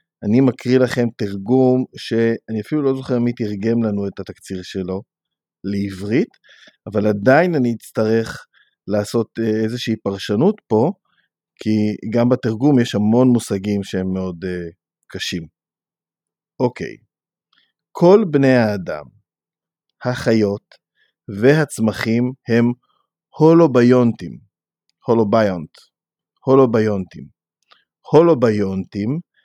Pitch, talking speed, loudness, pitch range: 115 Hz, 90 wpm, -18 LUFS, 100-125 Hz